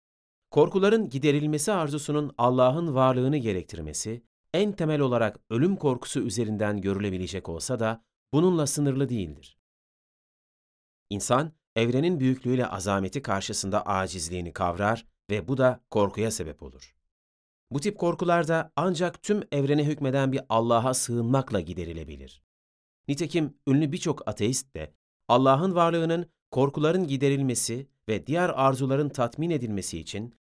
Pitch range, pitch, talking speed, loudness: 100-150 Hz, 125 Hz, 110 wpm, -26 LUFS